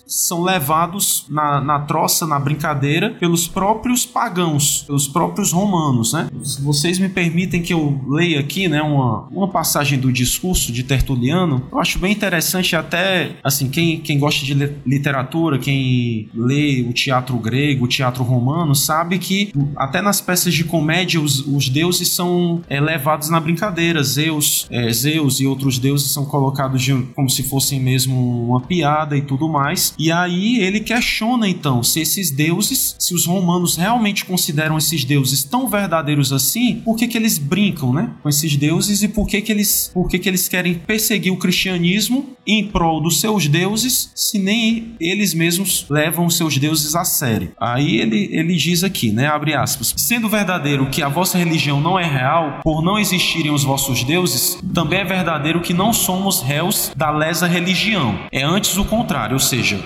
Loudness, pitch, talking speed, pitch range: -17 LUFS, 165 Hz, 175 wpm, 140-185 Hz